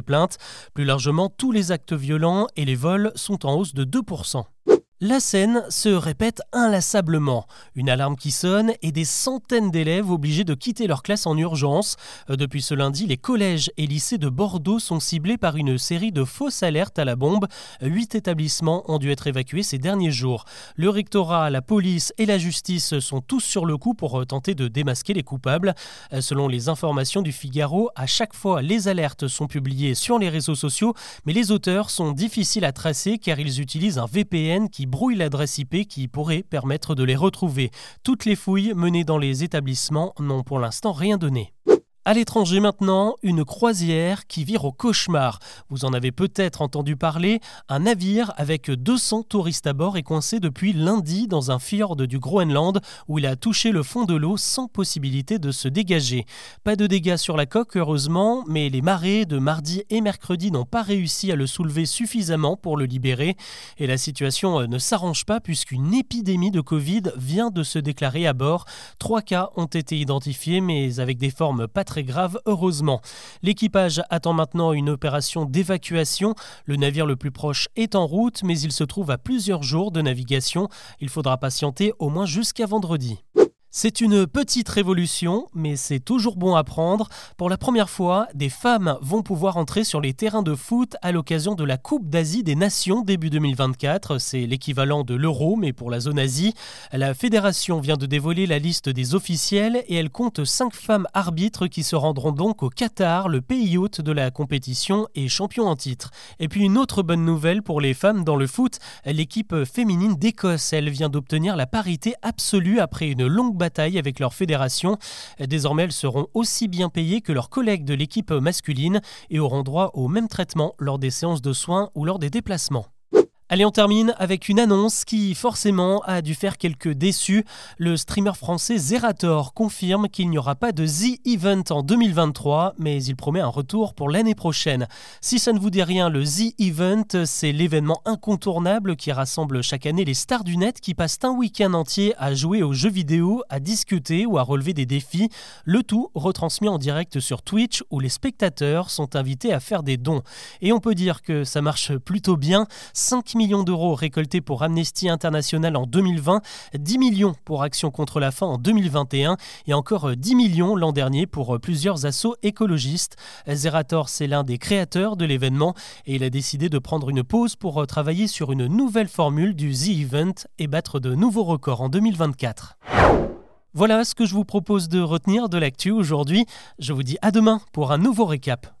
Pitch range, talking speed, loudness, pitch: 145-205 Hz, 190 wpm, -22 LUFS, 170 Hz